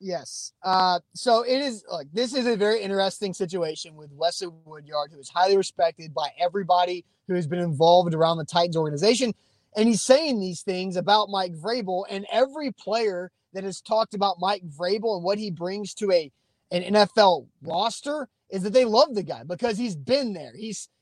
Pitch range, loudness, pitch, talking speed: 170-215 Hz, -24 LUFS, 190 Hz, 190 wpm